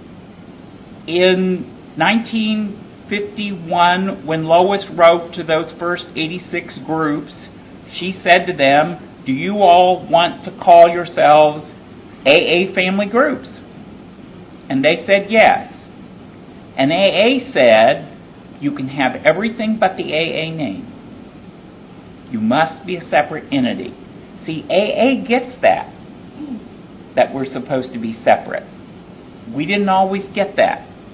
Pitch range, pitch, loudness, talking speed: 160-205 Hz, 180 Hz, -15 LUFS, 115 wpm